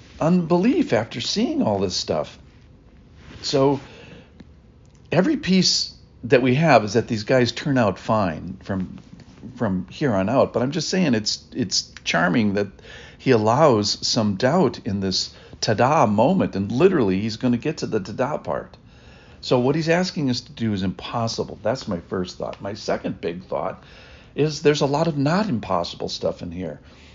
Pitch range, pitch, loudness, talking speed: 105-150 Hz, 125 Hz, -21 LUFS, 170 wpm